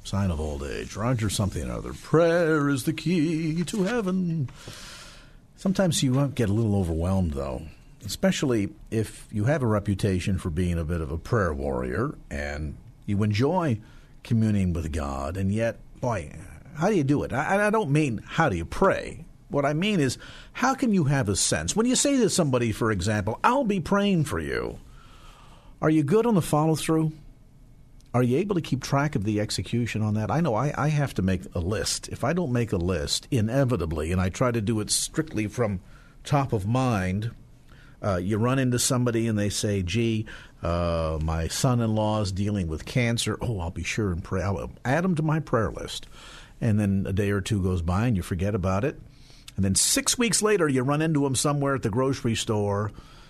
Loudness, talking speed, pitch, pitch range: -25 LUFS, 205 wpm, 115 Hz, 100-145 Hz